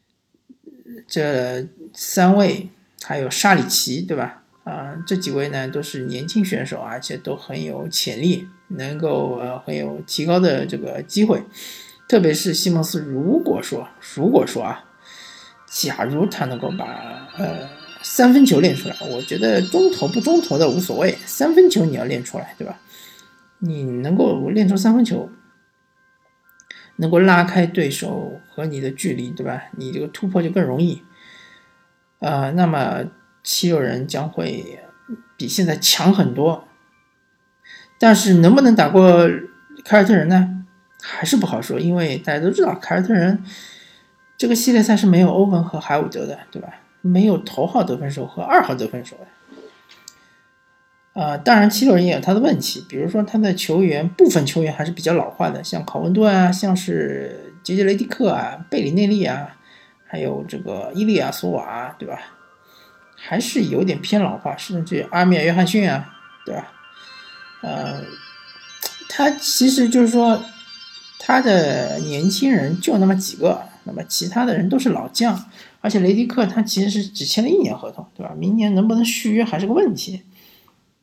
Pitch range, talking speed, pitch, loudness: 170-215 Hz, 245 characters per minute, 185 Hz, -18 LUFS